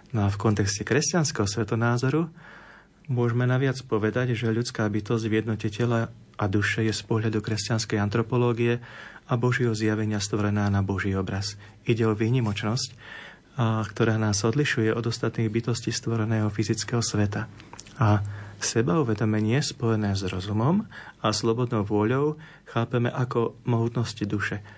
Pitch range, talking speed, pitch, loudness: 105-120 Hz, 130 wpm, 115 Hz, -26 LUFS